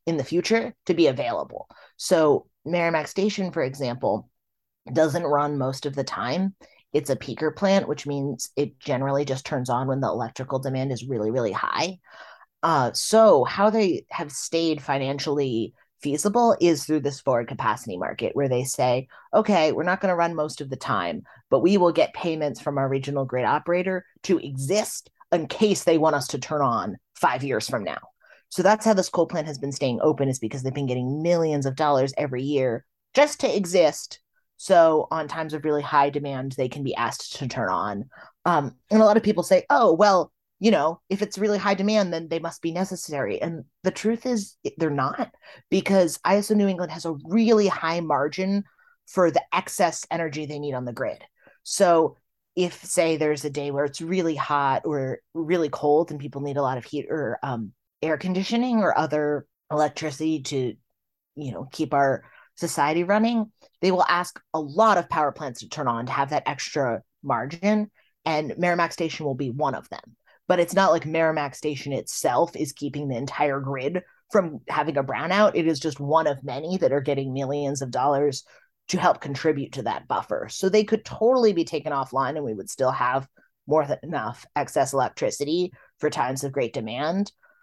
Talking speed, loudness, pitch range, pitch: 195 wpm, -24 LUFS, 140-185 Hz, 155 Hz